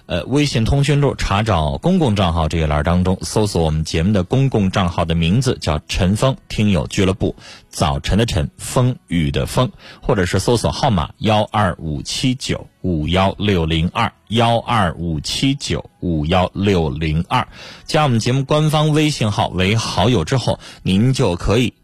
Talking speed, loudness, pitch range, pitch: 255 characters per minute, -18 LUFS, 85-120 Hz, 100 Hz